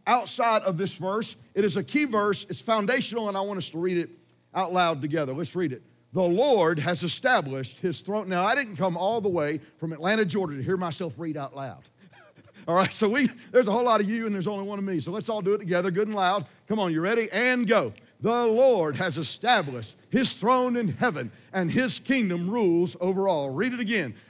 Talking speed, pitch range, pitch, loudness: 230 wpm, 170-220 Hz, 190 Hz, -26 LUFS